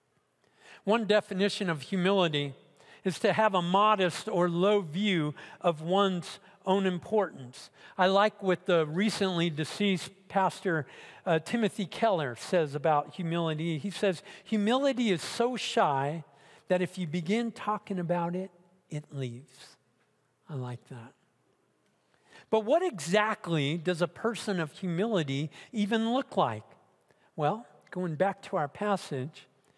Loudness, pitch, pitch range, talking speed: -30 LUFS, 185 Hz, 160-205 Hz, 130 wpm